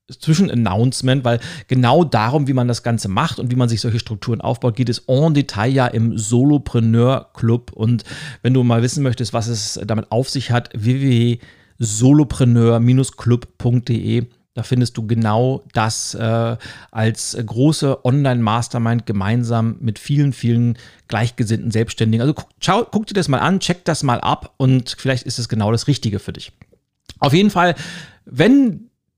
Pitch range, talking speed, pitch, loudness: 115-135 Hz, 155 wpm, 120 Hz, -17 LUFS